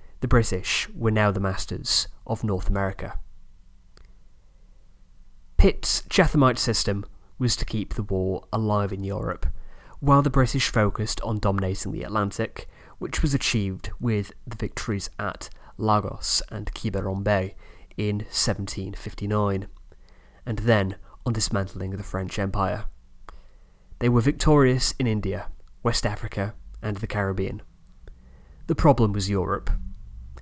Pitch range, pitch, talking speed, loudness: 95-110 Hz, 100 Hz, 120 wpm, -25 LUFS